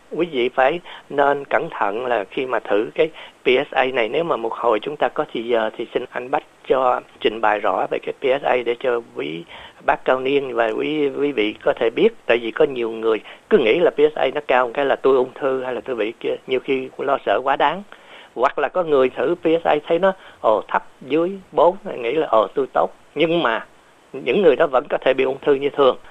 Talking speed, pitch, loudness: 235 wpm, 185 Hz, -20 LUFS